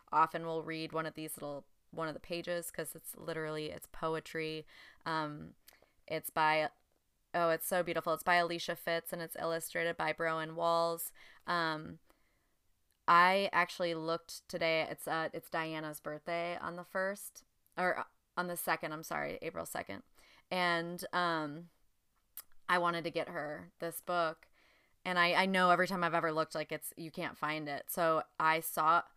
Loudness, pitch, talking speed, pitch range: -35 LUFS, 165 Hz, 165 wpm, 160-175 Hz